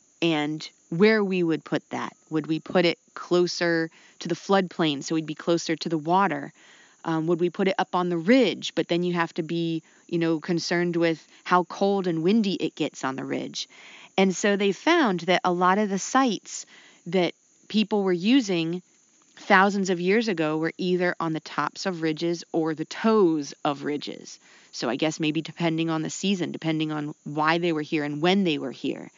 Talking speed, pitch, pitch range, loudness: 200 wpm, 170 Hz, 160-190 Hz, -25 LUFS